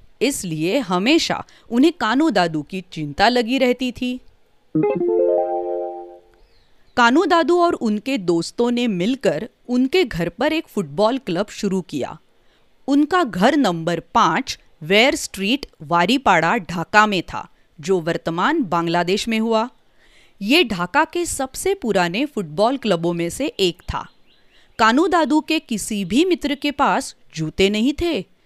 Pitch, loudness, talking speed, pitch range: 220 Hz, -19 LUFS, 125 wpm, 175-280 Hz